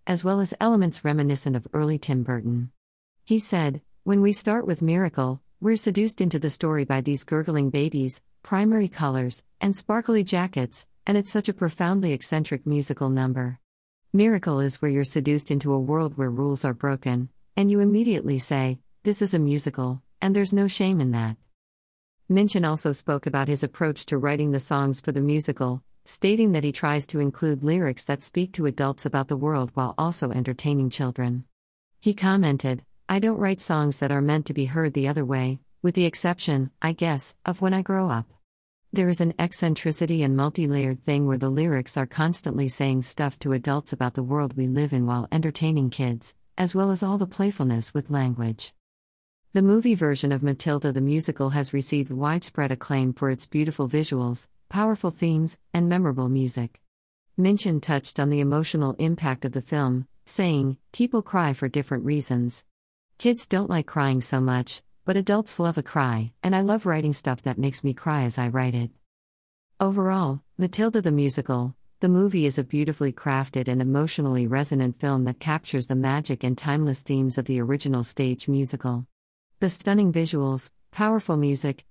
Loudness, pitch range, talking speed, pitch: -25 LUFS, 130-175 Hz, 180 wpm, 145 Hz